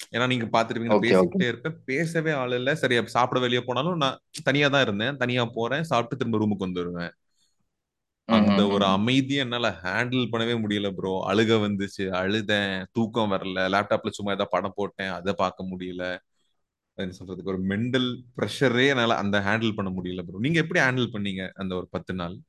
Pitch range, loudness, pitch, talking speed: 95-125 Hz, -25 LUFS, 105 Hz, 165 wpm